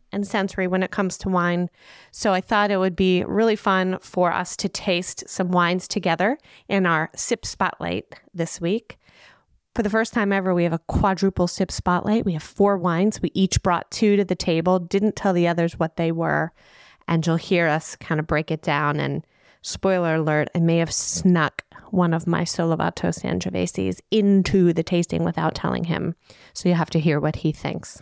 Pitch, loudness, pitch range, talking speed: 180 Hz, -22 LUFS, 165-195 Hz, 195 wpm